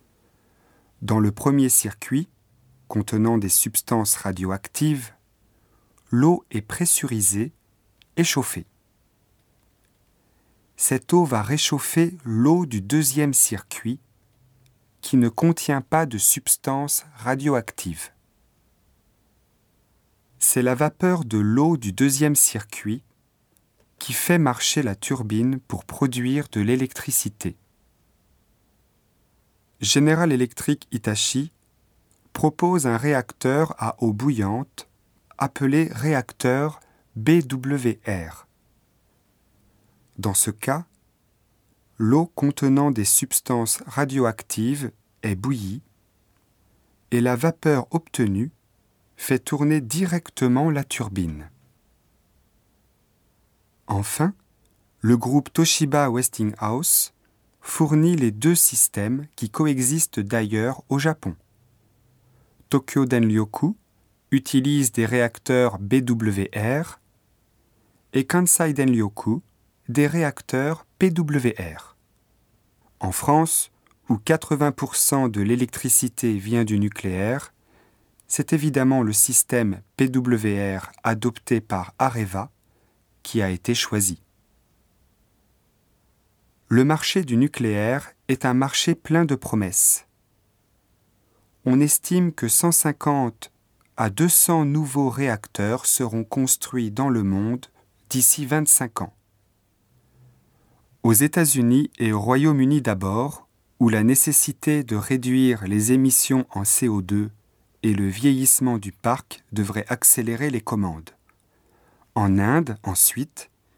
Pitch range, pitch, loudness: 105-140 Hz, 120 Hz, -21 LUFS